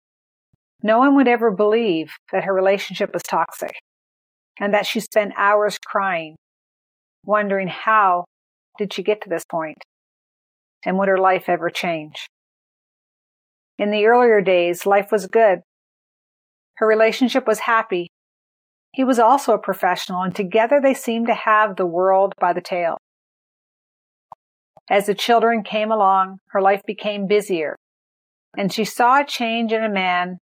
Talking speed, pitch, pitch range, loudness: 145 wpm, 205 Hz, 190-225 Hz, -19 LUFS